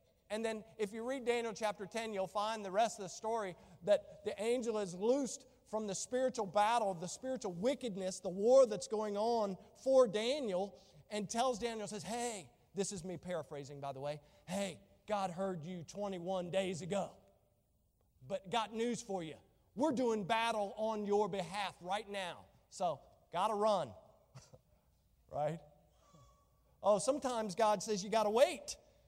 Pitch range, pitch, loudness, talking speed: 190-225 Hz, 210 Hz, -37 LUFS, 165 wpm